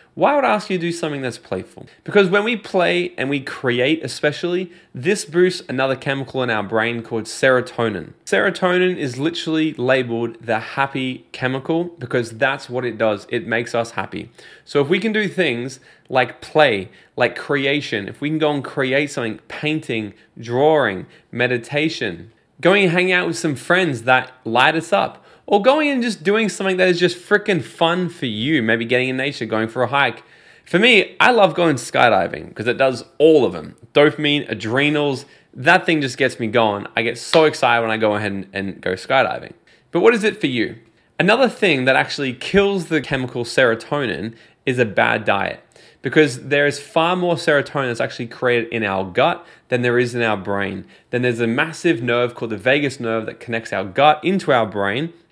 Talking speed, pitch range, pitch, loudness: 195 wpm, 115-165 Hz, 135 Hz, -18 LUFS